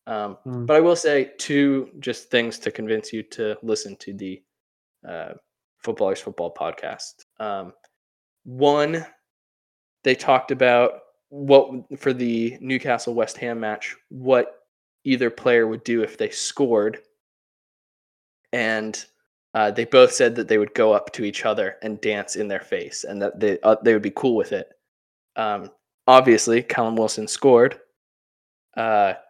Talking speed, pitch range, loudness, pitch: 150 wpm, 110-140 Hz, -21 LUFS, 125 Hz